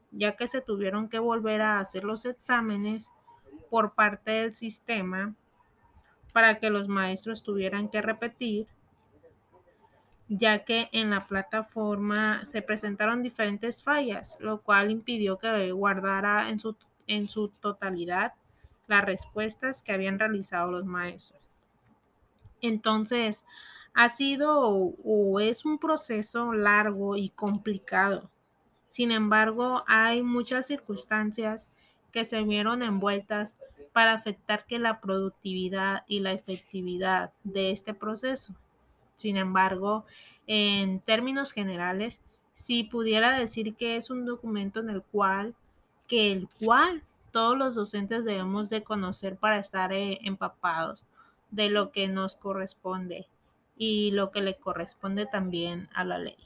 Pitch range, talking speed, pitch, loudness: 195-225 Hz, 125 wpm, 215 Hz, -28 LUFS